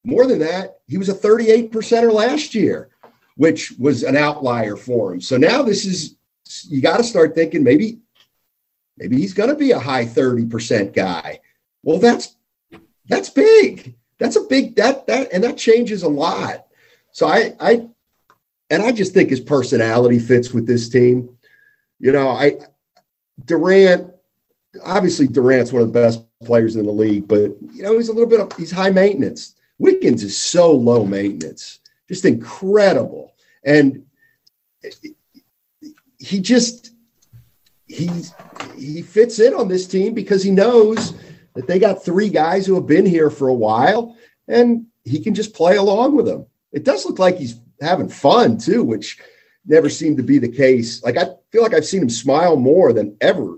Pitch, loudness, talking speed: 185 Hz, -16 LUFS, 170 wpm